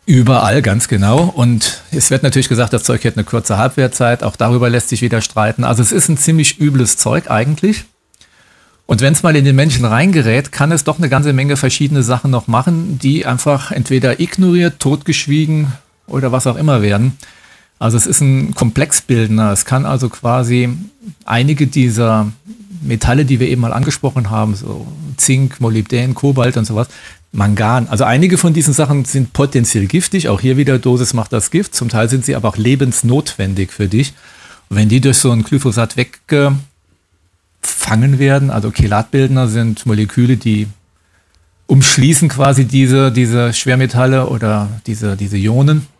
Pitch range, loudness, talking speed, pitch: 115-140 Hz, -13 LUFS, 170 wpm, 130 Hz